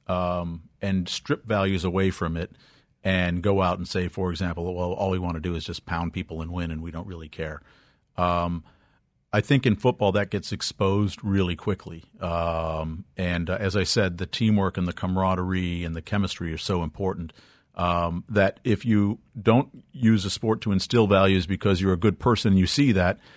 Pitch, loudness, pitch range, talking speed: 95 Hz, -25 LUFS, 85-105 Hz, 200 wpm